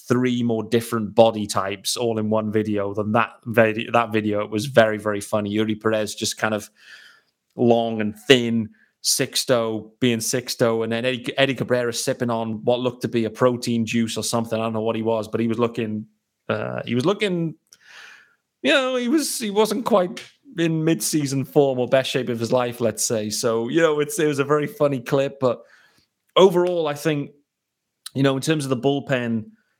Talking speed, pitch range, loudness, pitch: 195 wpm, 110-140 Hz, -21 LUFS, 120 Hz